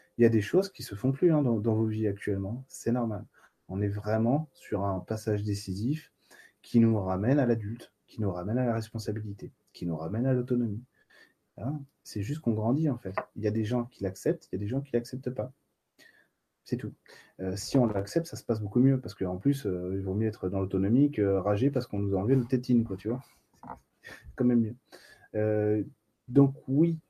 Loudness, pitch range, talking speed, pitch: -30 LUFS, 105-130 Hz, 225 wpm, 115 Hz